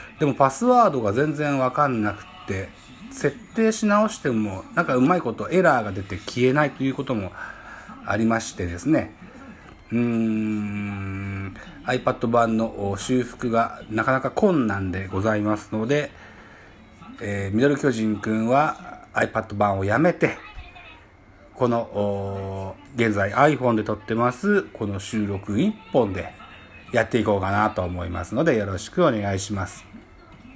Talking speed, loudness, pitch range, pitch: 285 characters per minute, -23 LUFS, 100-130 Hz, 110 Hz